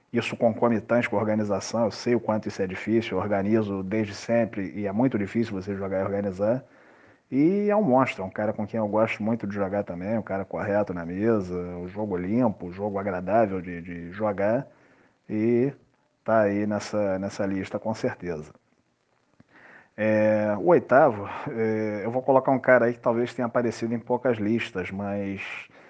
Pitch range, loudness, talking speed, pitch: 100-115 Hz, -26 LUFS, 185 wpm, 105 Hz